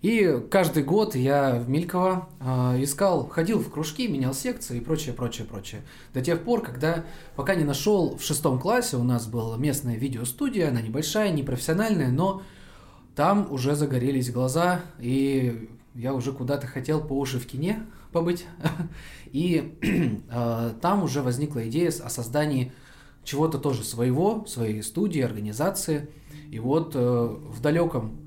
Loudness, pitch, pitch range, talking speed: -26 LUFS, 145 Hz, 125-170 Hz, 140 wpm